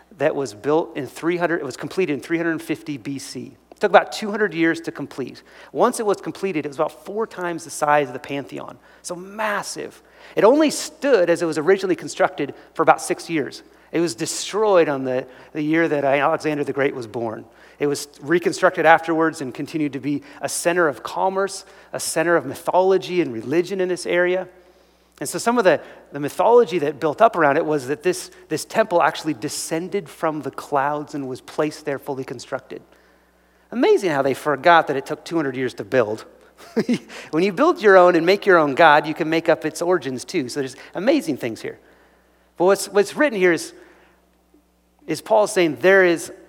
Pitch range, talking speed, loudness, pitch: 145-185 Hz, 195 wpm, -20 LUFS, 165 Hz